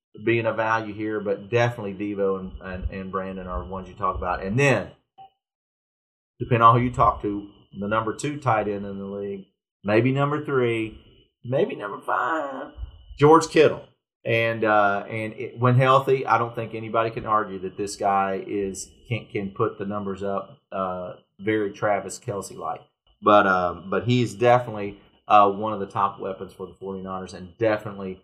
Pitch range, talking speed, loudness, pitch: 95-115 Hz, 175 wpm, -23 LUFS, 105 Hz